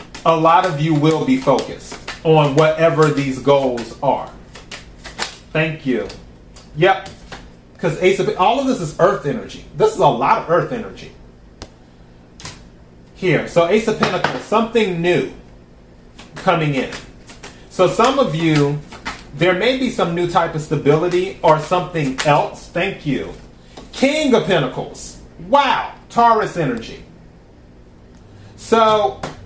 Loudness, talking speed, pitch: -17 LUFS, 130 wpm, 155 Hz